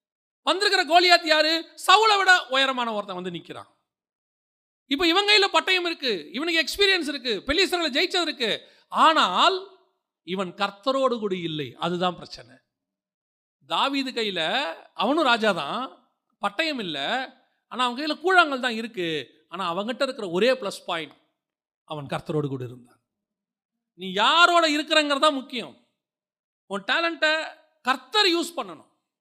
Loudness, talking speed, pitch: -22 LUFS, 120 wpm, 260 Hz